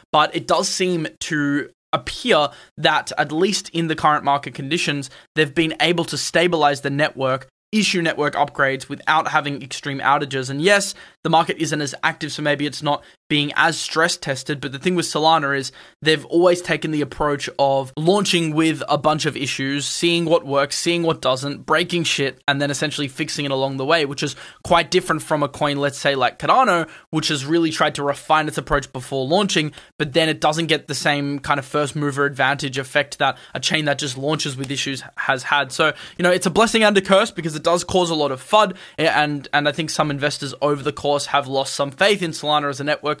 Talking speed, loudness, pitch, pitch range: 215 wpm, -20 LUFS, 150 Hz, 140-165 Hz